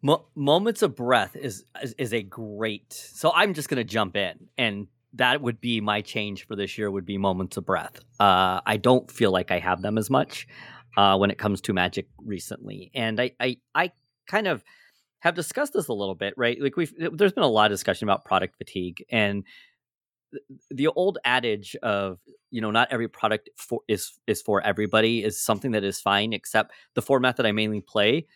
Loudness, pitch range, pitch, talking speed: -25 LUFS, 100-125 Hz, 110 Hz, 205 wpm